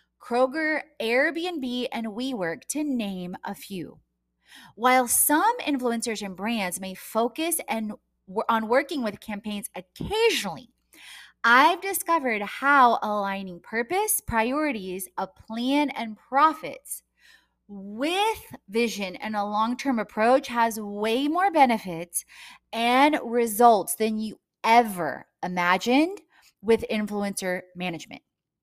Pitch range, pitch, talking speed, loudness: 205-275 Hz, 230 Hz, 105 wpm, -25 LUFS